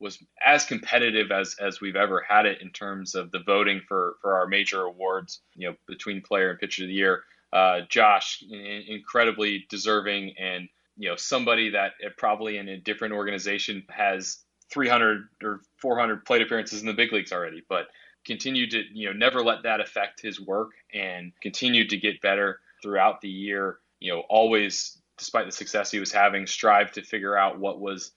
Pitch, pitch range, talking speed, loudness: 100 Hz, 95-105 Hz, 190 wpm, -25 LUFS